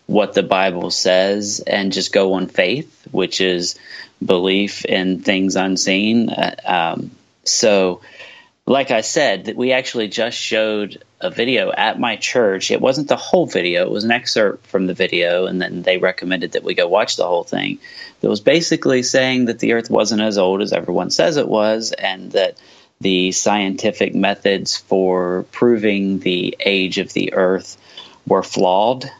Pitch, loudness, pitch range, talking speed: 100 Hz, -17 LUFS, 95-115 Hz, 170 wpm